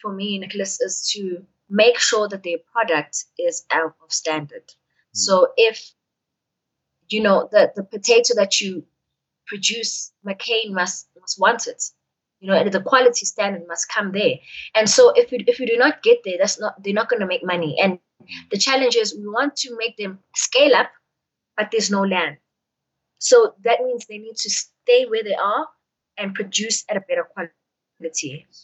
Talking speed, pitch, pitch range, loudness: 180 wpm, 210 Hz, 190-245 Hz, -19 LUFS